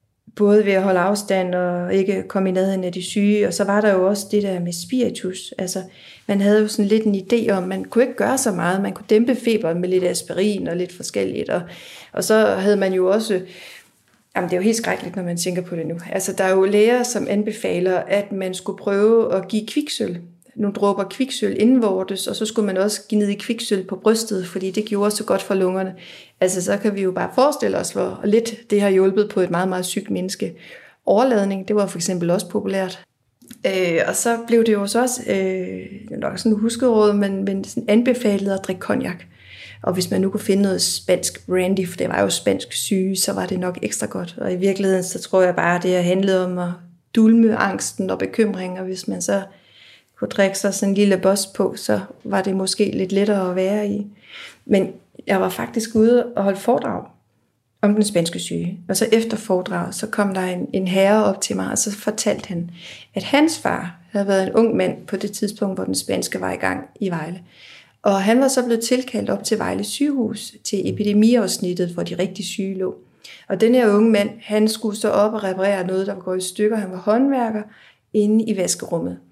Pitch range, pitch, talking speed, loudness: 185-215 Hz, 200 Hz, 220 wpm, -20 LUFS